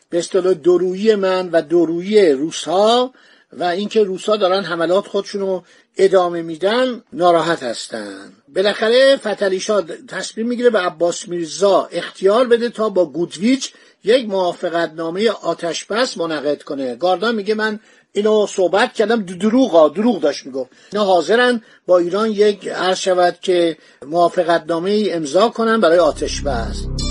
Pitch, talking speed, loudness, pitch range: 195 Hz, 130 wpm, -17 LUFS, 175-220 Hz